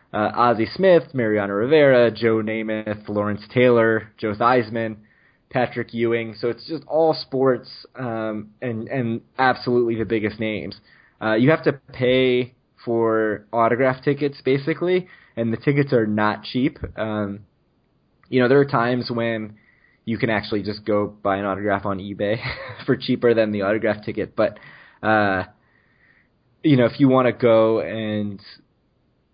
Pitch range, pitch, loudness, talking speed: 105-130 Hz, 115 Hz, -21 LUFS, 150 wpm